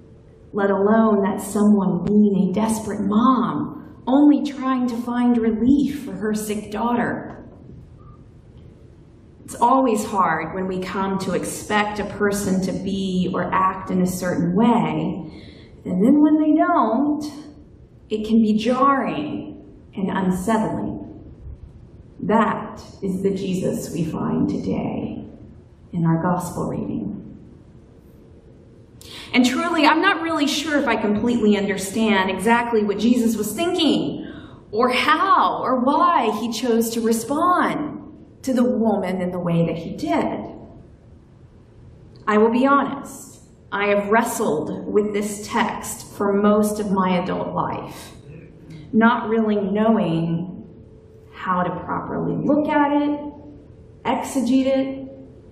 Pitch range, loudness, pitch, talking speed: 195-260 Hz, -20 LUFS, 220 Hz, 125 wpm